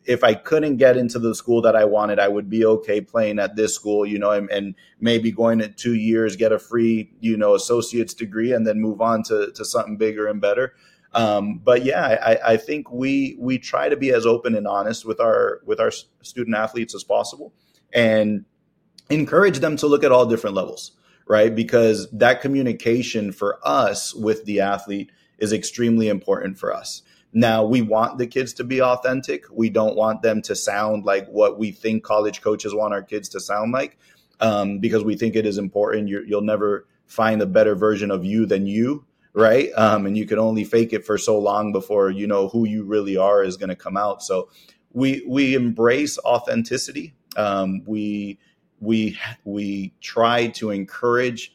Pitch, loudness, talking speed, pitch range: 110 Hz, -20 LUFS, 195 wpm, 105-120 Hz